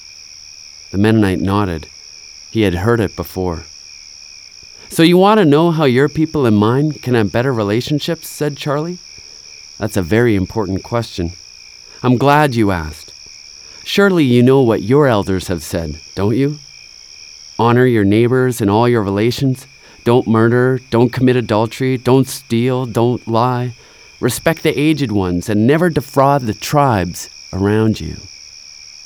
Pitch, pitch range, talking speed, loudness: 115 Hz, 95-130 Hz, 145 wpm, -15 LUFS